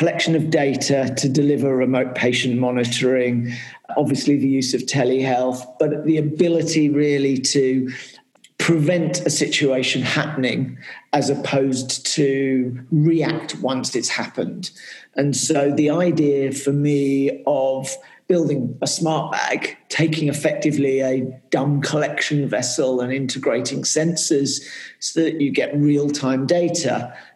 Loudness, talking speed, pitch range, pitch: -20 LUFS, 125 wpm, 130-155 Hz, 140 Hz